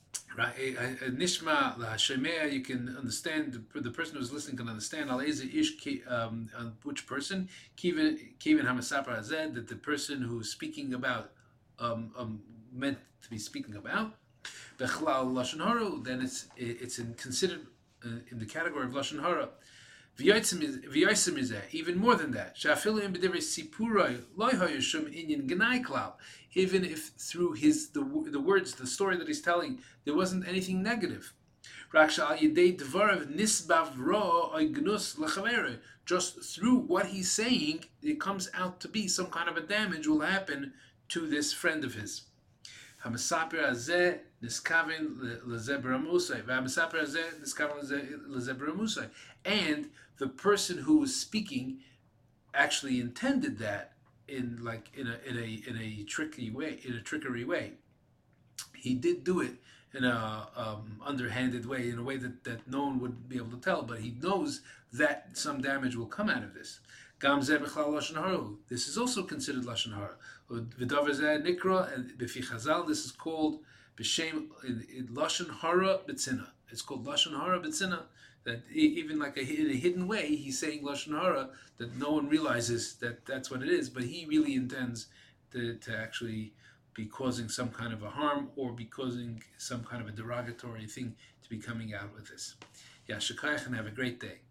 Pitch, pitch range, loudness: 140 Hz, 120-185 Hz, -32 LUFS